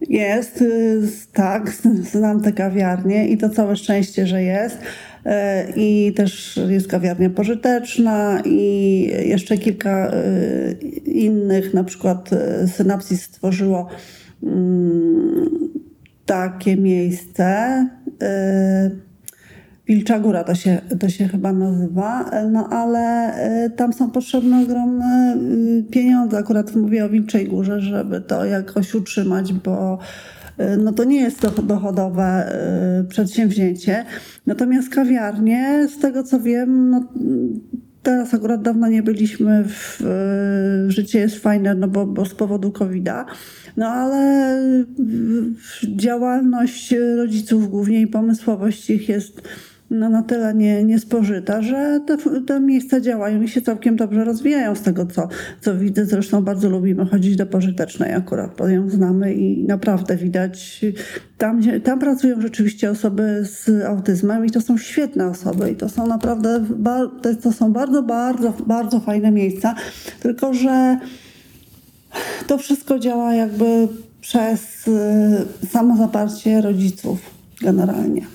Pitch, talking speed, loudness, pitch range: 215 Hz, 125 wpm, -18 LUFS, 195-235 Hz